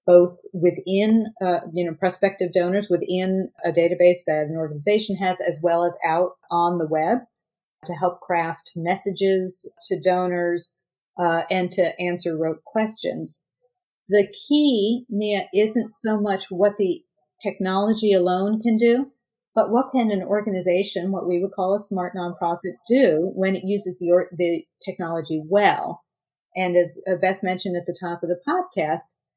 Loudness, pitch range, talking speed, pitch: -22 LUFS, 175-205 Hz, 155 wpm, 185 Hz